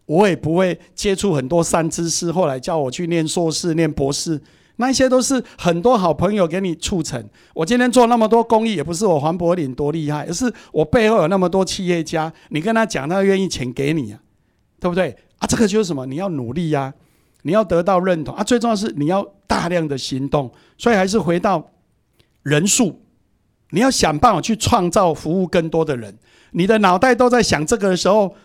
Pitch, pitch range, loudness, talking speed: 175 Hz, 155-210 Hz, -18 LUFS, 305 characters per minute